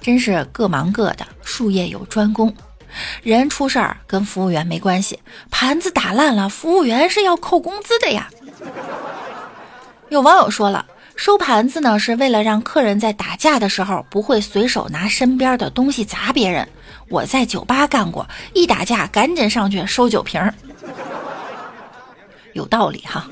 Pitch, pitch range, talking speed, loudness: 230 Hz, 205-280 Hz, 235 characters per minute, -16 LUFS